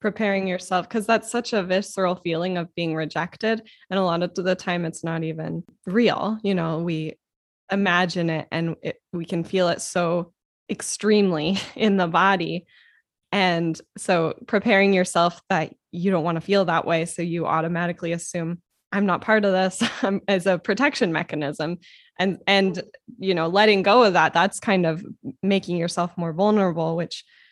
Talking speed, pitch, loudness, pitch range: 170 wpm, 185 Hz, -23 LUFS, 170-200 Hz